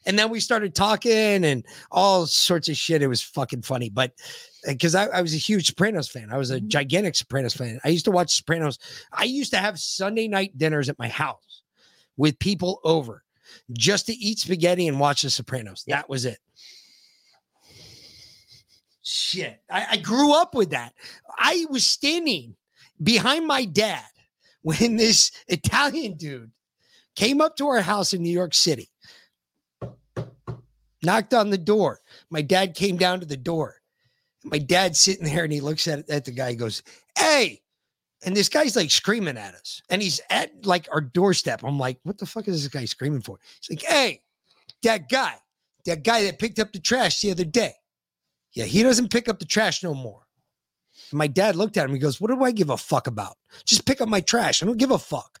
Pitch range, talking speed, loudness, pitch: 140-210 Hz, 195 wpm, -22 LUFS, 180 Hz